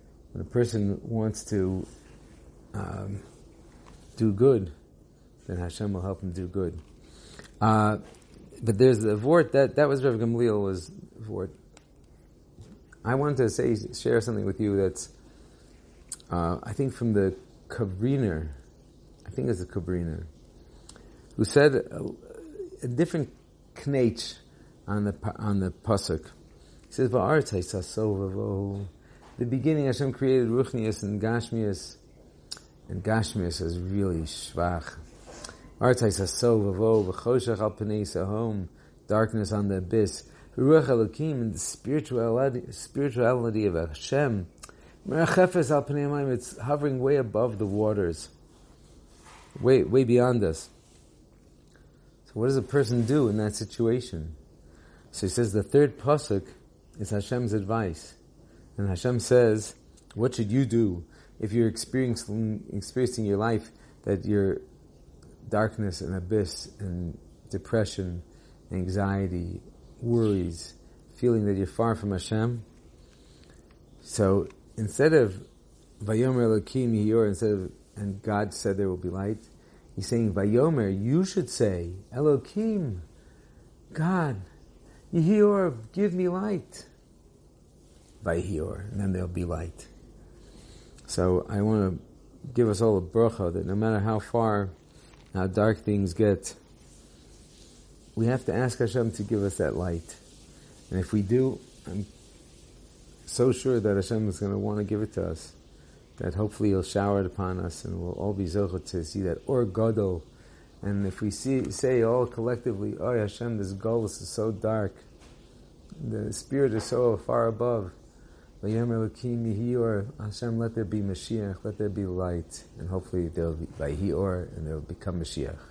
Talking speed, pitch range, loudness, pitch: 135 wpm, 90-120 Hz, -27 LUFS, 105 Hz